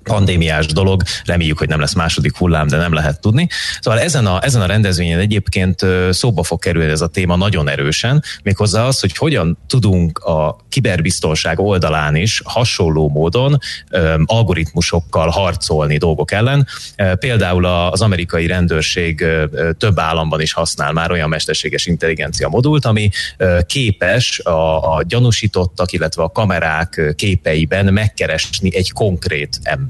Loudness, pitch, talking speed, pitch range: -15 LUFS, 90 Hz, 135 wpm, 80-105 Hz